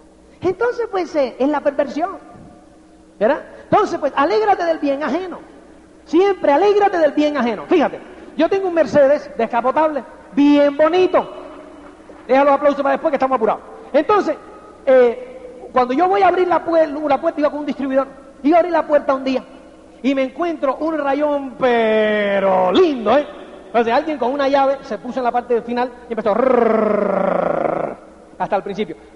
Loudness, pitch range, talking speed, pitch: -17 LUFS, 260-325 Hz, 170 wpm, 290 Hz